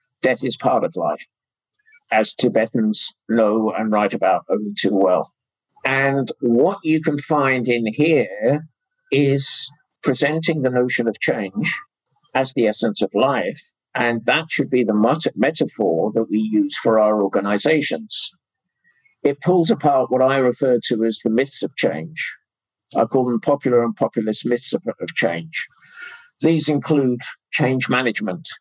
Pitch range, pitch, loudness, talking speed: 115-155 Hz, 130 Hz, -19 LUFS, 150 wpm